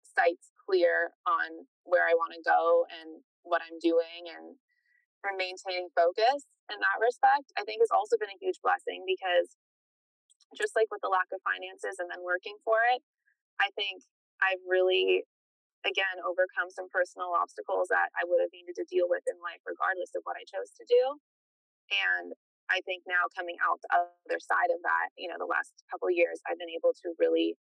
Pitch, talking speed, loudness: 215 Hz, 195 wpm, -30 LUFS